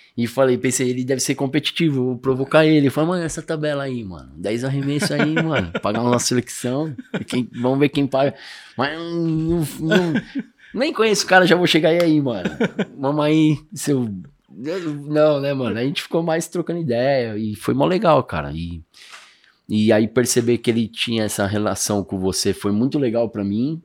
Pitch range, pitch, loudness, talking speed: 115-160 Hz, 135 Hz, -20 LUFS, 185 wpm